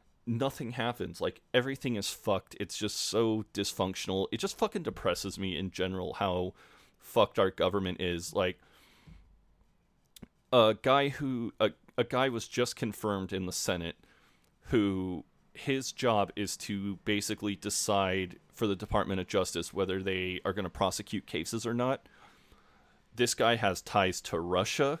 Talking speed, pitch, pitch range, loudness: 150 wpm, 105 Hz, 95-120 Hz, -32 LUFS